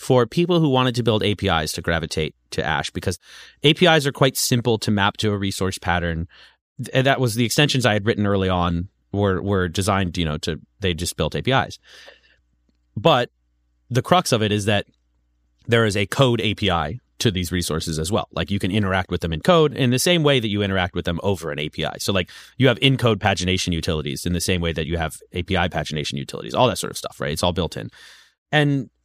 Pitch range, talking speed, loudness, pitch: 85-120 Hz, 220 wpm, -21 LUFS, 95 Hz